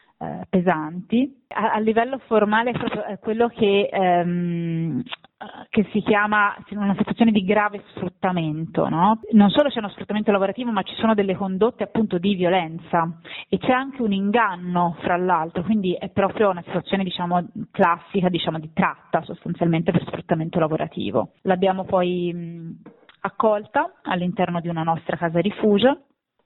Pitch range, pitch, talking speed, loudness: 175-215 Hz, 195 Hz, 145 wpm, -22 LUFS